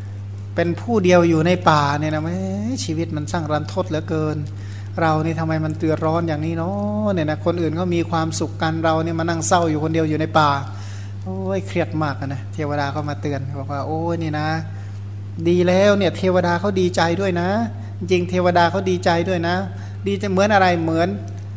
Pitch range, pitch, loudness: 100-160 Hz, 140 Hz, -20 LUFS